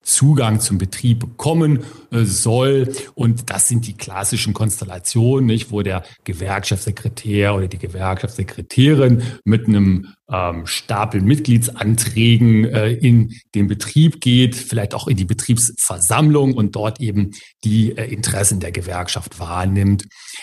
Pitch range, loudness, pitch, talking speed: 100-120 Hz, -17 LUFS, 110 Hz, 125 wpm